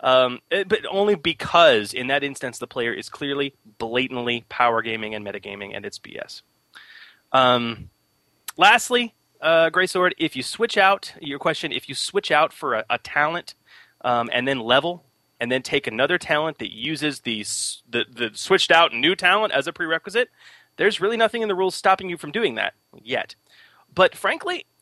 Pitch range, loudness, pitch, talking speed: 120-180 Hz, -21 LUFS, 140 Hz, 180 wpm